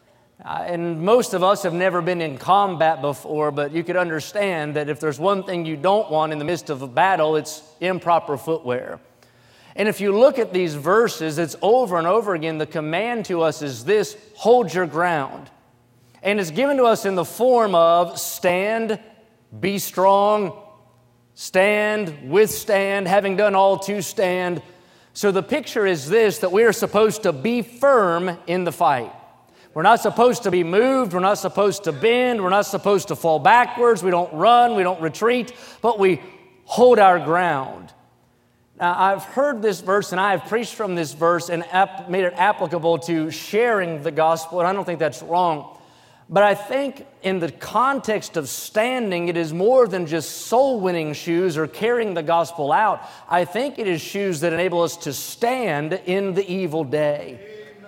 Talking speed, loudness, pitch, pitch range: 180 wpm, -20 LUFS, 185 Hz, 165-210 Hz